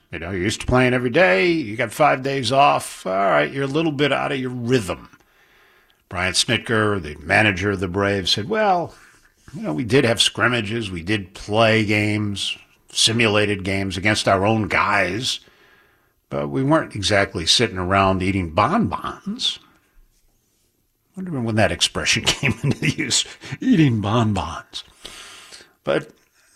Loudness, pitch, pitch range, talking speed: -19 LUFS, 105 Hz, 100-125 Hz, 150 wpm